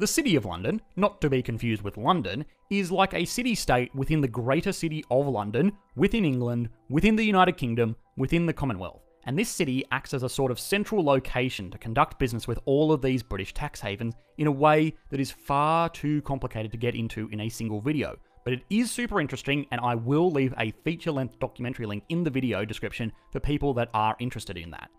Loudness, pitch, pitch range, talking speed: -27 LUFS, 135 Hz, 115-160 Hz, 215 wpm